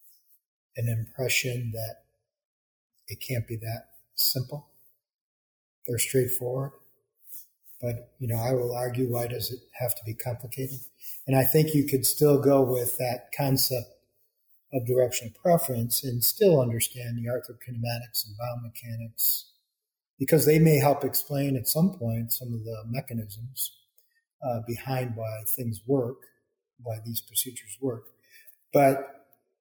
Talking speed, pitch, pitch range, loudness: 140 wpm, 125 Hz, 115-135 Hz, -27 LUFS